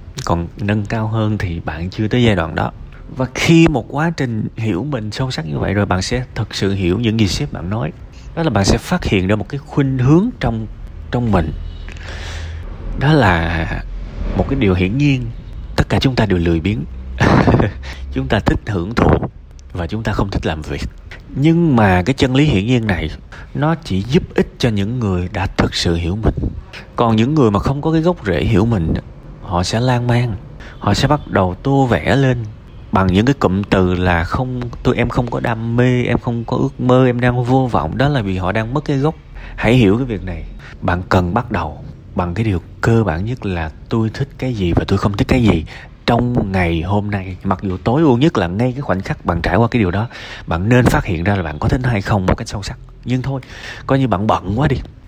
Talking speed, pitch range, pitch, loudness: 235 wpm, 90-125 Hz, 110 Hz, -17 LUFS